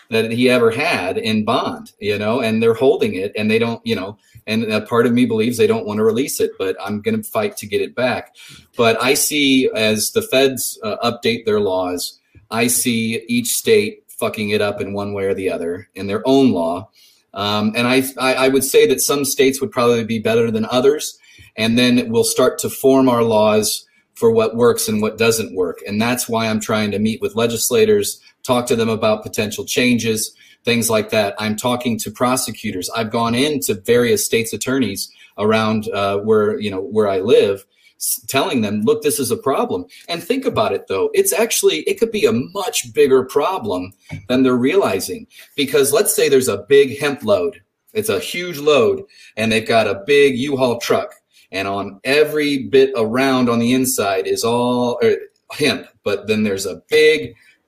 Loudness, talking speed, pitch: -17 LUFS, 200 wpm, 175 Hz